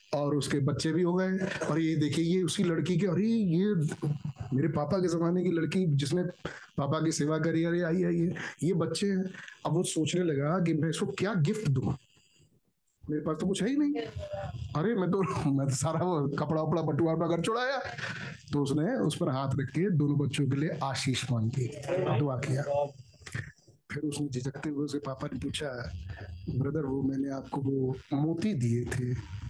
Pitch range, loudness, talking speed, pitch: 140-175 Hz, -30 LUFS, 195 wpm, 155 Hz